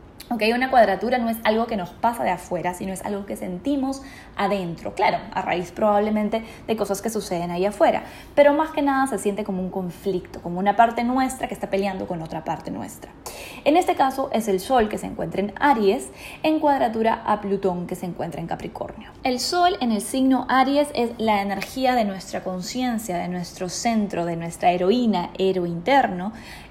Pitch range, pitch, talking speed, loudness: 185-255 Hz, 210 Hz, 195 wpm, -23 LUFS